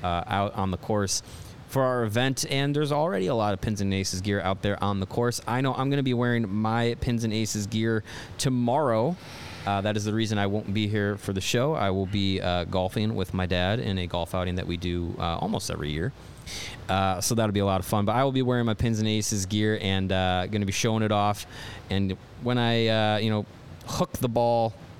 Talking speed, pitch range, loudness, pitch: 240 wpm, 95-115 Hz, -26 LUFS, 105 Hz